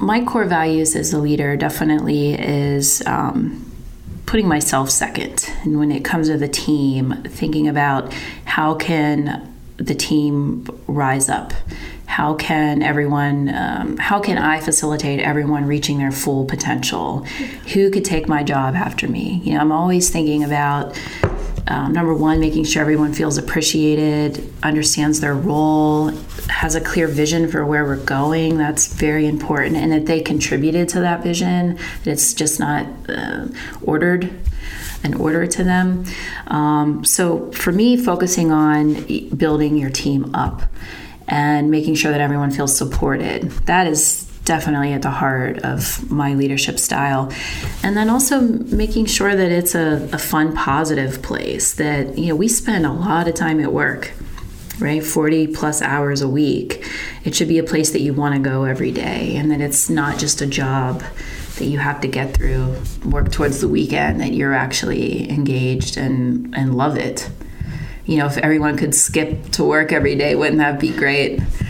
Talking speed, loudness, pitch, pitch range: 165 wpm, -18 LUFS, 150 Hz, 140-160 Hz